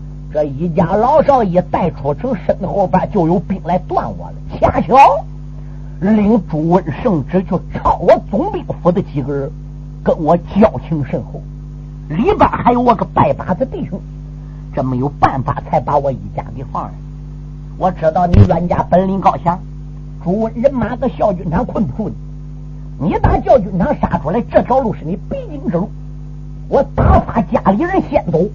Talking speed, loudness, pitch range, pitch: 240 characters per minute, -15 LUFS, 145-190 Hz, 165 Hz